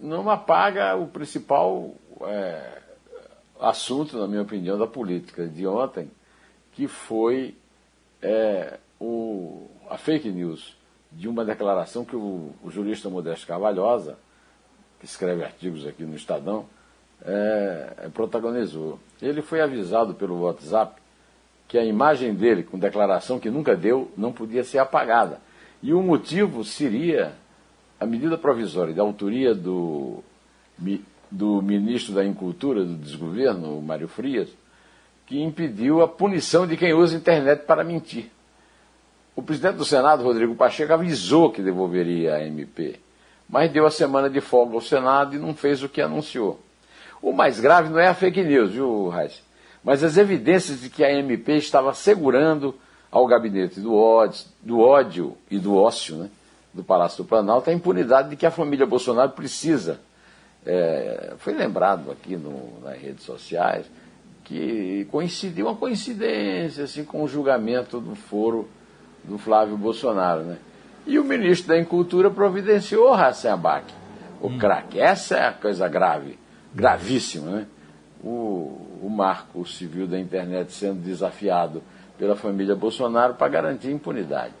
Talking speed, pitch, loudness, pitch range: 145 wpm, 120 Hz, -22 LUFS, 100-155 Hz